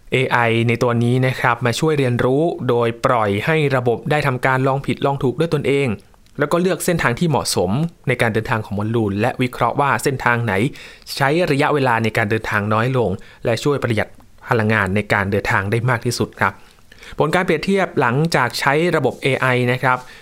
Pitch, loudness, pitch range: 125 Hz, -18 LUFS, 115-145 Hz